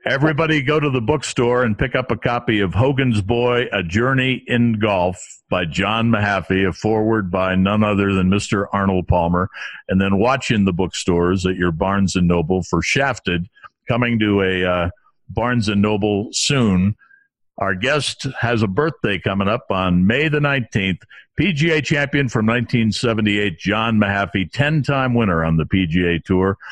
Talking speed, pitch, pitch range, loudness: 160 wpm, 105 Hz, 95-125 Hz, -18 LUFS